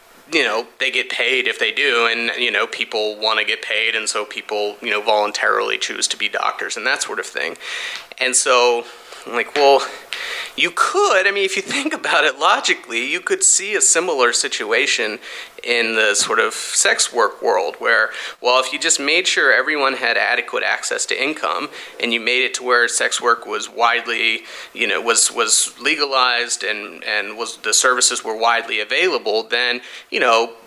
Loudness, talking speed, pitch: -17 LUFS, 190 wpm, 375 Hz